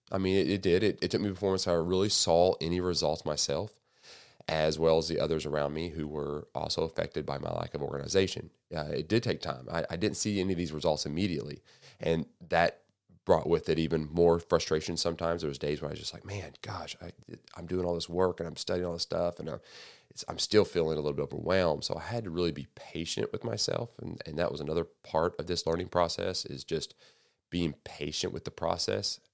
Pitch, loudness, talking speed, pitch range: 85 Hz, -31 LUFS, 230 wpm, 80-90 Hz